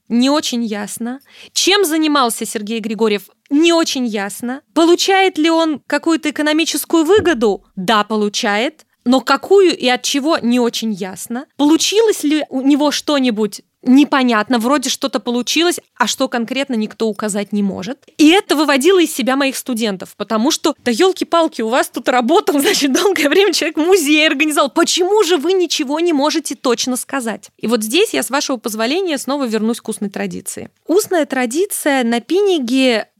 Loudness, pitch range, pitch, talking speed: -15 LUFS, 235-325 Hz, 275 Hz, 160 wpm